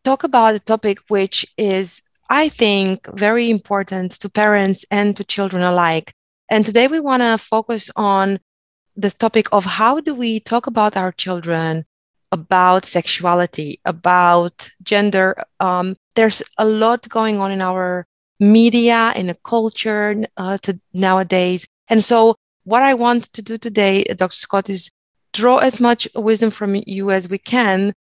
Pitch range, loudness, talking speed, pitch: 185-225 Hz, -16 LUFS, 155 wpm, 205 Hz